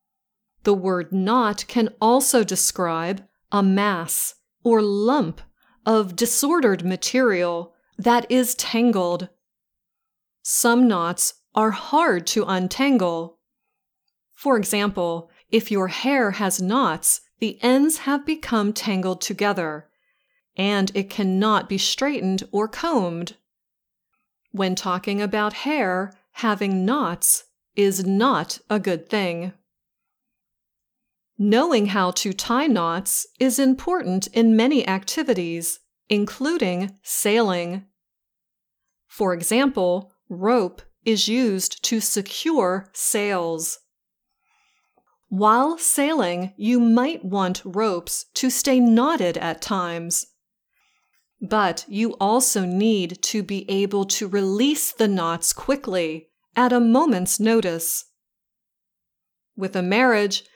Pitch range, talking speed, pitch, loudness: 185-245 Hz, 100 wpm, 205 Hz, -21 LUFS